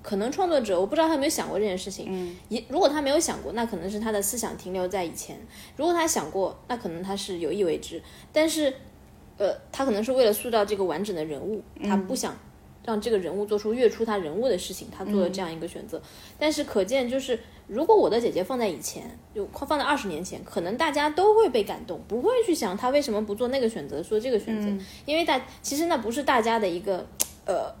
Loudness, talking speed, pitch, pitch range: -26 LUFS, 355 characters per minute, 225 Hz, 195-290 Hz